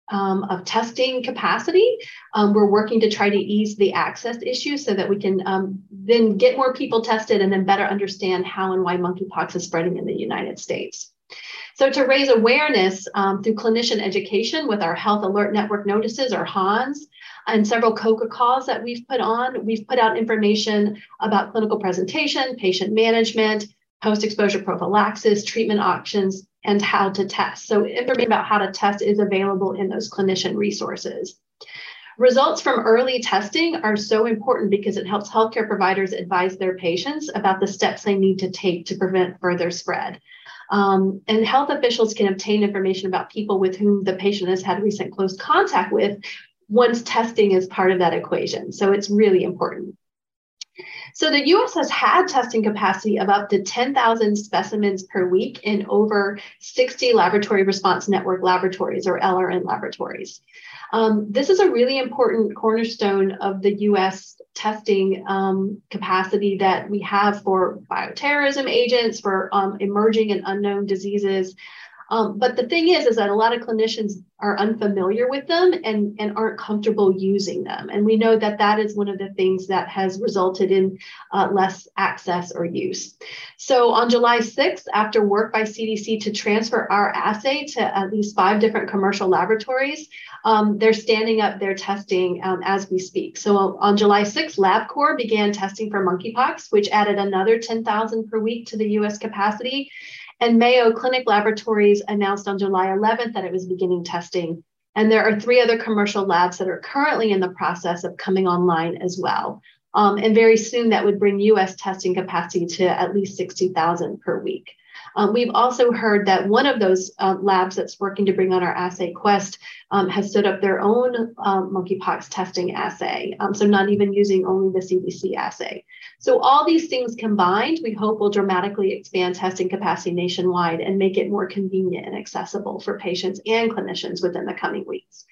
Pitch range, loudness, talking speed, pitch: 190-225 Hz, -20 LUFS, 175 wpm, 205 Hz